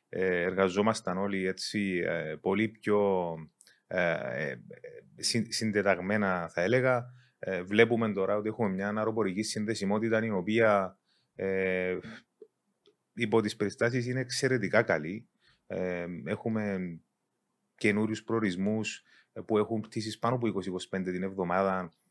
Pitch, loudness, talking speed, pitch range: 105 Hz, -30 LUFS, 90 wpm, 95-115 Hz